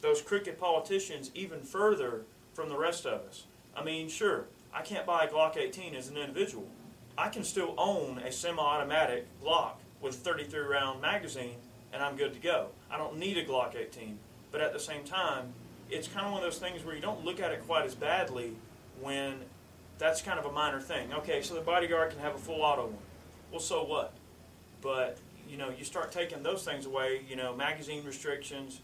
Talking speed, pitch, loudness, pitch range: 205 wpm, 145 Hz, -34 LUFS, 130-170 Hz